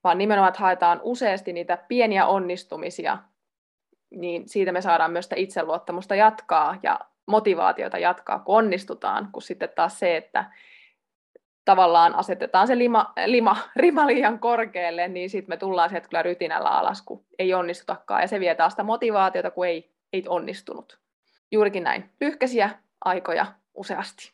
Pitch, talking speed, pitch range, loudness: 190 Hz, 150 wpm, 175-220 Hz, -23 LUFS